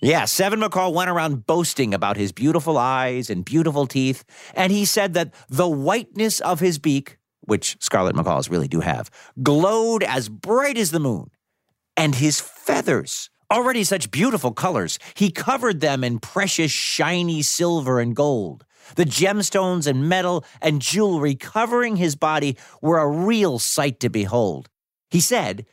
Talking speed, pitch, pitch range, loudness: 160 wpm, 160 Hz, 135-190 Hz, -21 LUFS